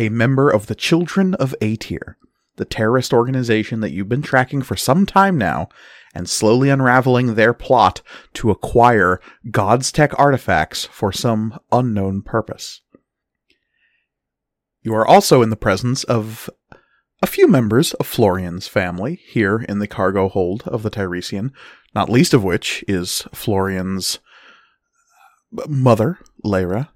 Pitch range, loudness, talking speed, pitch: 100-130 Hz, -17 LUFS, 135 wpm, 115 Hz